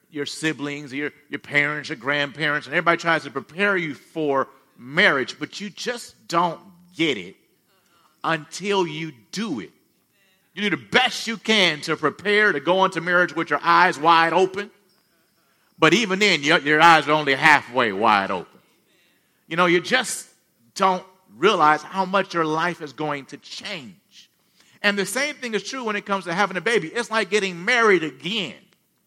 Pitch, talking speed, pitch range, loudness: 175 Hz, 175 wpm, 155-205 Hz, -21 LUFS